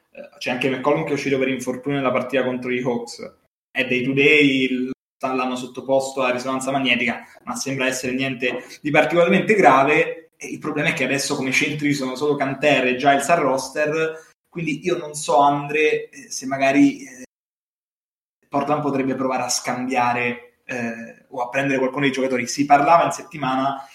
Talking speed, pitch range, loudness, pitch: 170 wpm, 130-150 Hz, -20 LUFS, 135 Hz